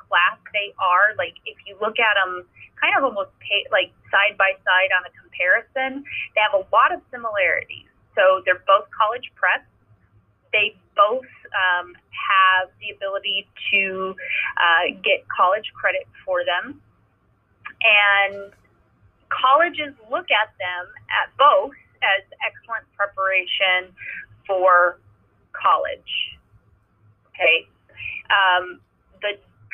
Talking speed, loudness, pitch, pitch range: 120 wpm, -20 LUFS, 195 Hz, 180-260 Hz